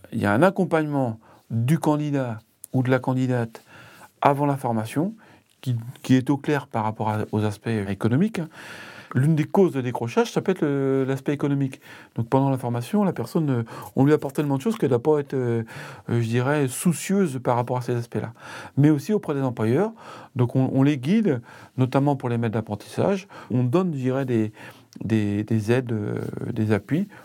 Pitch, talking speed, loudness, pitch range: 130 Hz, 185 wpm, -24 LUFS, 115-150 Hz